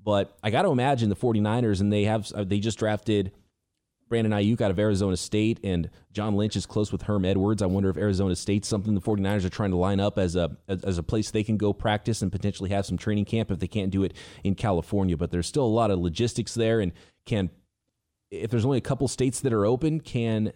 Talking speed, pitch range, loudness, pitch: 240 wpm, 95-110 Hz, -26 LUFS, 105 Hz